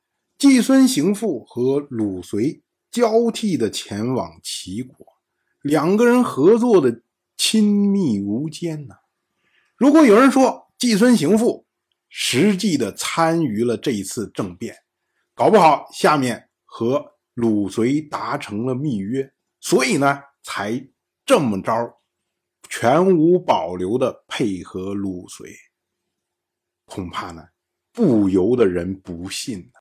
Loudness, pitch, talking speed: -19 LUFS, 145 Hz, 170 characters per minute